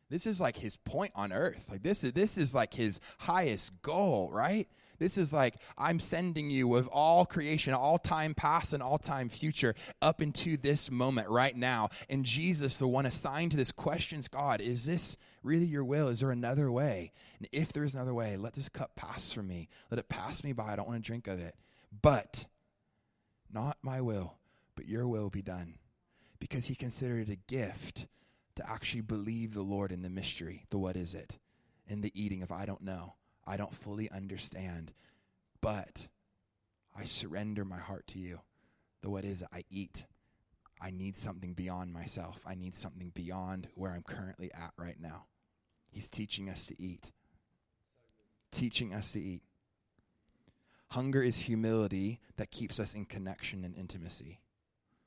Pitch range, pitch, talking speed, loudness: 95-135 Hz, 110 Hz, 180 wpm, -35 LUFS